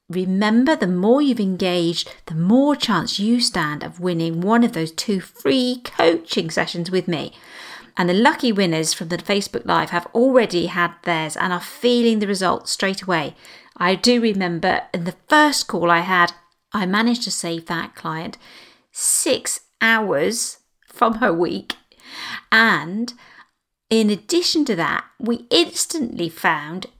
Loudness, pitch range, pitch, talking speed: -19 LUFS, 175-235 Hz, 195 Hz, 150 wpm